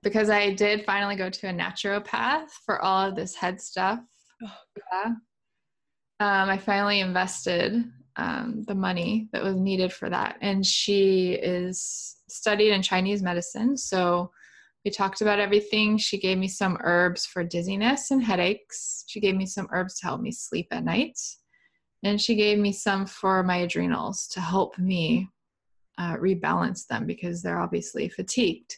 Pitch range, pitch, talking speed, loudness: 185-210 Hz, 195 Hz, 160 wpm, -26 LUFS